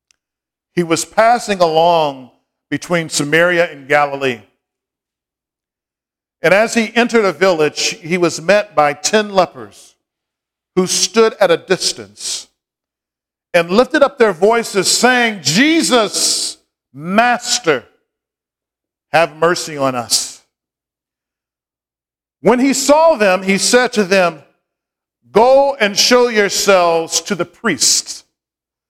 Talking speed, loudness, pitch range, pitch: 110 wpm, -13 LUFS, 160-230 Hz, 185 Hz